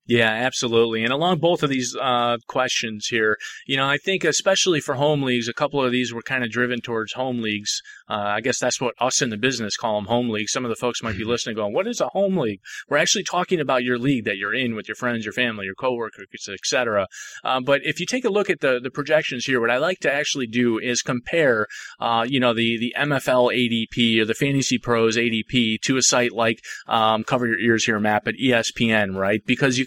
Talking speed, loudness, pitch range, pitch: 240 wpm, -21 LUFS, 115-135 Hz, 125 Hz